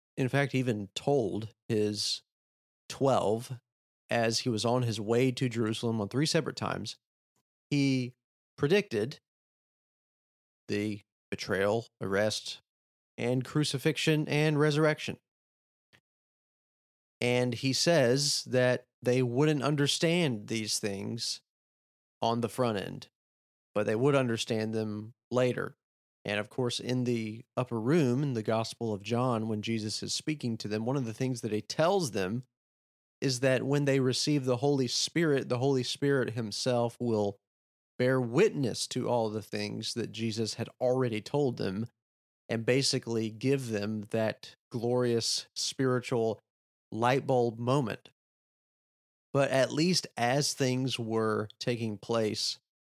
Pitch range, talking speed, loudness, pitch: 110-135 Hz, 130 wpm, -30 LUFS, 120 Hz